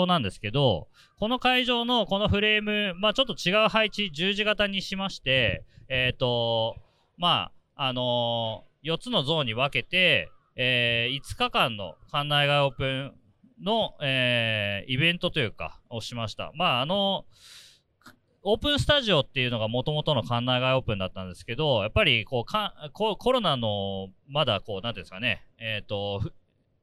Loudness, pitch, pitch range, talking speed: -25 LUFS, 135 Hz, 115-190 Hz, 330 characters per minute